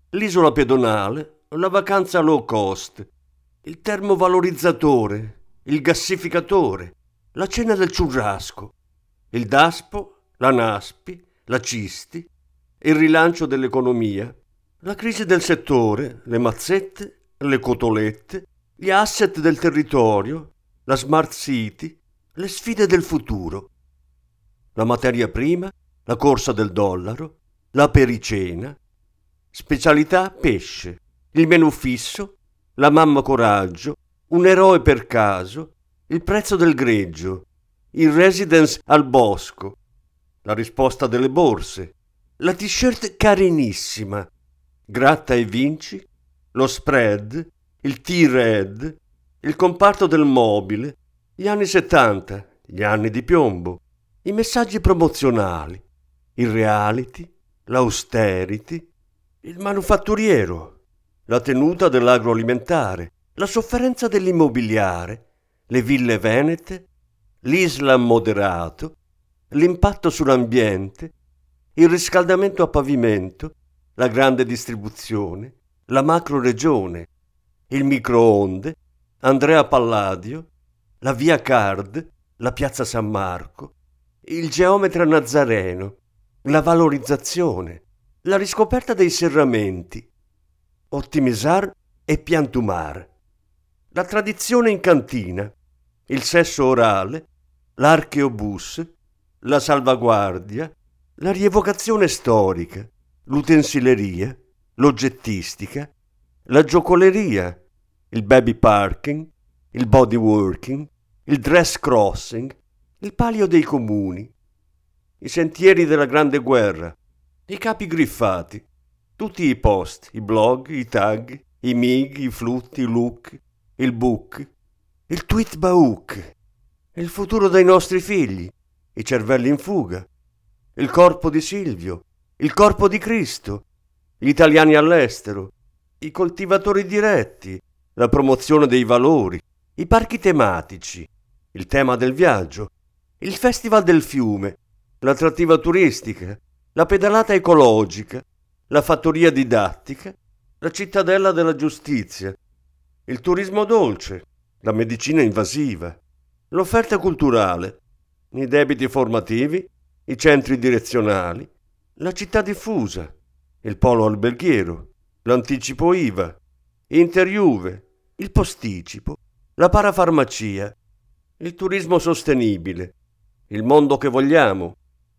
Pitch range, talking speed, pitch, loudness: 95-165 Hz, 100 wpm, 125 Hz, -18 LUFS